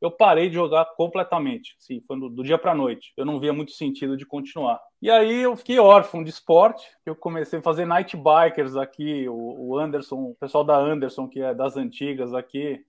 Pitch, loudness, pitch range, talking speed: 155 Hz, -21 LUFS, 135-175 Hz, 205 wpm